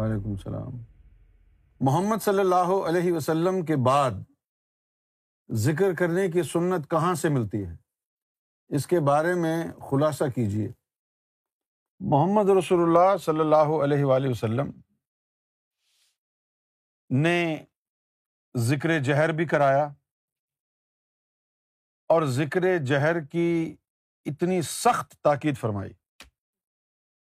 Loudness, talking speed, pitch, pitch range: -24 LUFS, 95 wpm, 155 Hz, 125-175 Hz